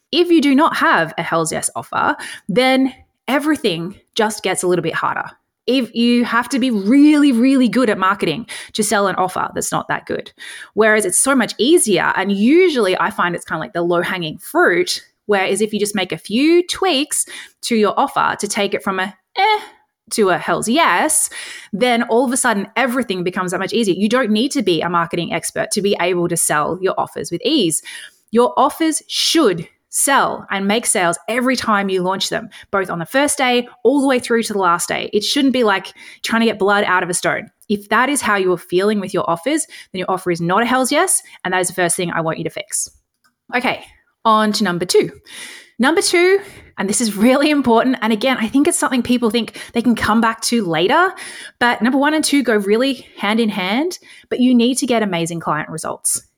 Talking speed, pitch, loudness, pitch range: 225 wpm, 225 Hz, -16 LUFS, 190-275 Hz